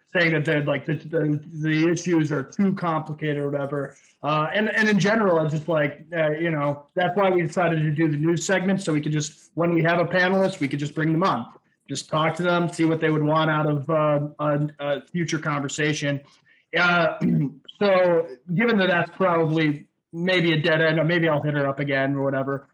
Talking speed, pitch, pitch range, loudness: 220 wpm, 160 Hz, 150-175 Hz, -23 LUFS